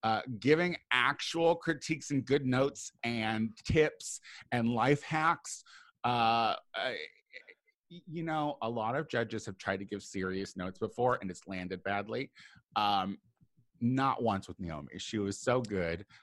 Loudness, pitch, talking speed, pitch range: -33 LUFS, 120 Hz, 150 wpm, 100-155 Hz